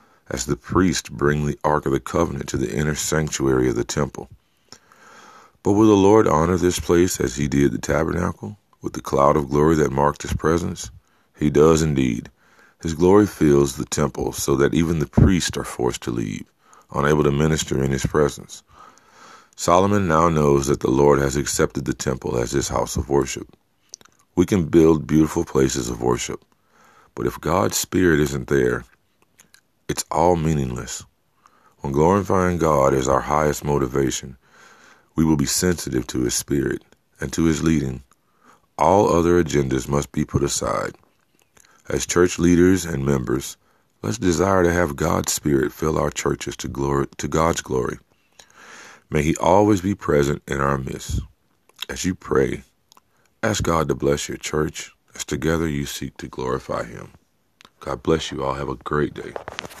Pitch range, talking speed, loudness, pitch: 70-85 Hz, 170 wpm, -20 LUFS, 75 Hz